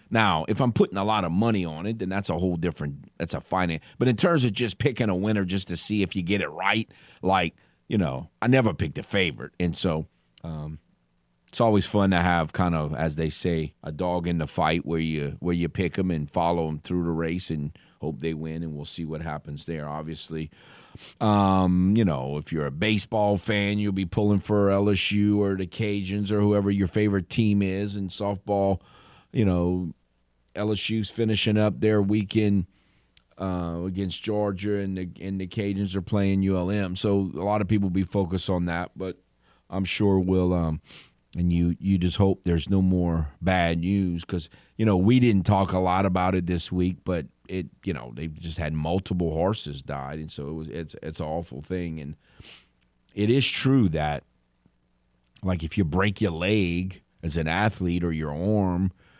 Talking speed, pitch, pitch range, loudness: 200 wpm, 95 Hz, 80-100 Hz, -26 LUFS